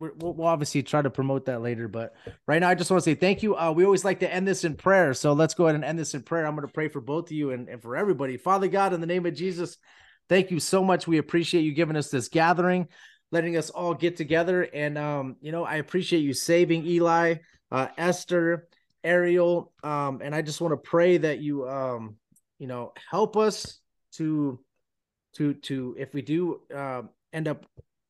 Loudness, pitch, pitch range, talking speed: -26 LUFS, 160 Hz, 140-175 Hz, 225 wpm